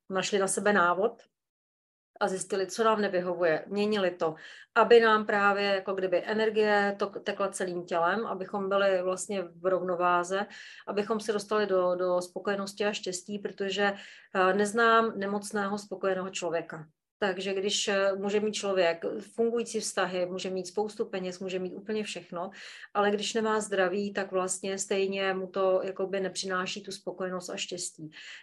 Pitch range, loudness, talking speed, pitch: 185-205 Hz, -29 LUFS, 145 wpm, 195 Hz